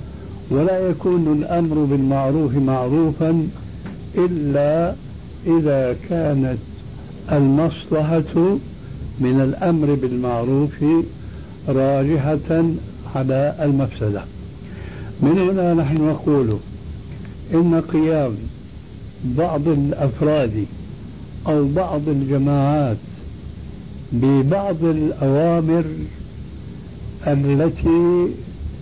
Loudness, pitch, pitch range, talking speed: -19 LUFS, 145 Hz, 135-165 Hz, 60 wpm